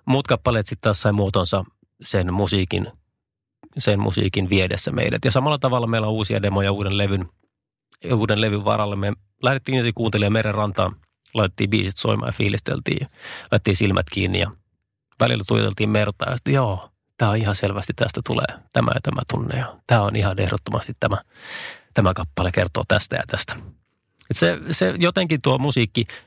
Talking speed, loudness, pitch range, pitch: 165 wpm, -21 LUFS, 100-120 Hz, 105 Hz